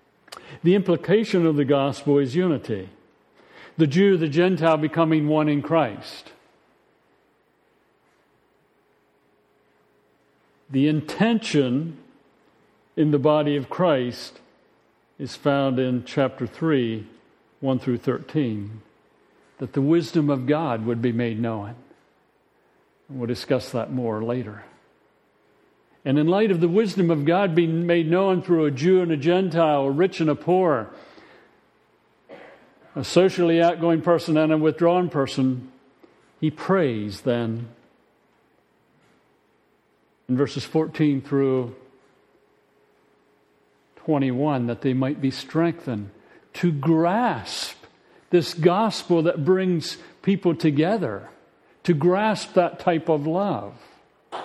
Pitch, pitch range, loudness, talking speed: 155 Hz, 130-170 Hz, -22 LUFS, 110 wpm